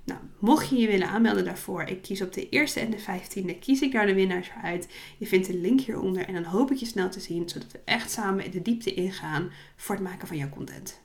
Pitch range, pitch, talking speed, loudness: 180-220 Hz, 190 Hz, 260 wpm, -27 LUFS